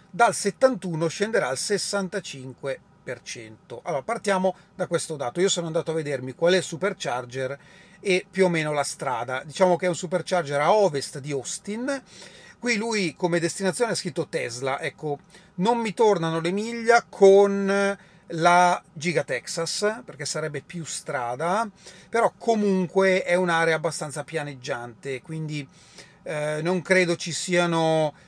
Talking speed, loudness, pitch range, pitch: 140 wpm, -24 LUFS, 155-195 Hz, 175 Hz